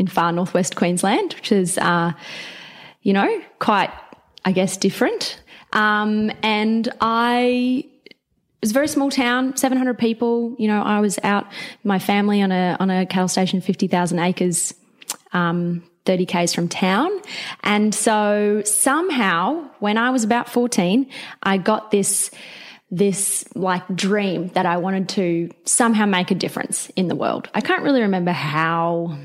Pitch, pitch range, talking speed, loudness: 205 Hz, 185-240 Hz, 160 wpm, -20 LUFS